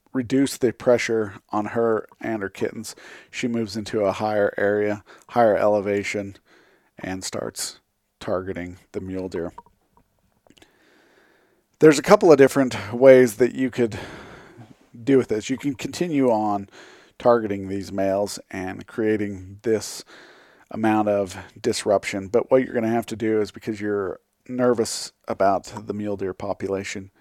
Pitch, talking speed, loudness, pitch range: 105 Hz, 140 wpm, -22 LUFS, 100-120 Hz